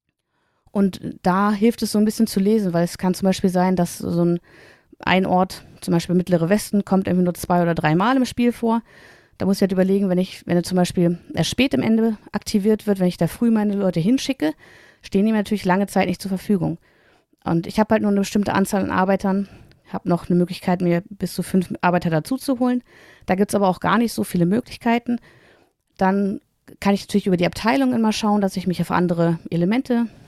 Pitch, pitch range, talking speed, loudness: 195 Hz, 180-215 Hz, 220 wpm, -20 LUFS